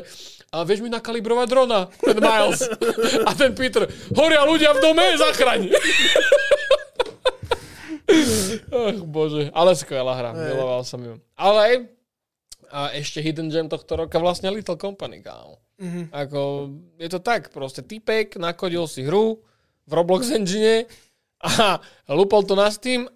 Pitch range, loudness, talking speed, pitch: 160-245 Hz, -20 LUFS, 135 wpm, 200 Hz